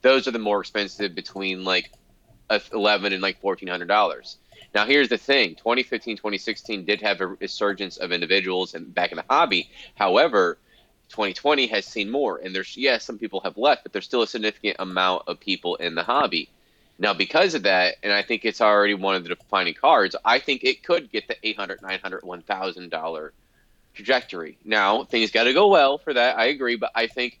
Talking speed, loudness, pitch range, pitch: 195 wpm, -22 LUFS, 95-115 Hz, 100 Hz